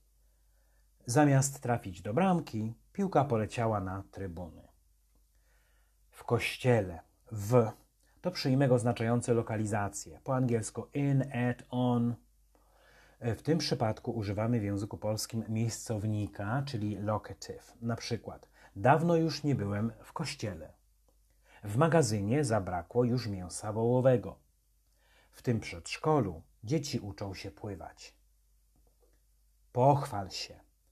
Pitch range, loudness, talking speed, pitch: 100-125 Hz, -32 LUFS, 105 wpm, 110 Hz